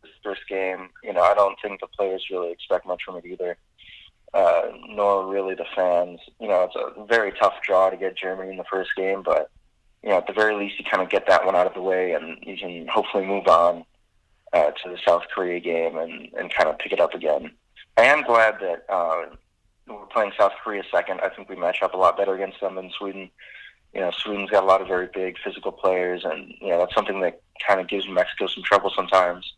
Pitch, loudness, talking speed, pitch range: 95 Hz, -23 LUFS, 240 wpm, 90-100 Hz